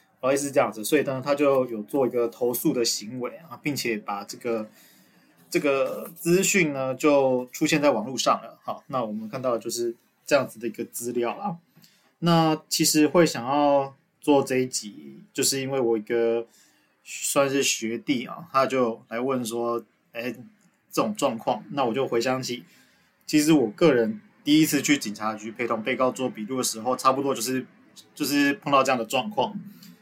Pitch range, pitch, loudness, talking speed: 120-150 Hz, 130 Hz, -25 LUFS, 265 characters per minute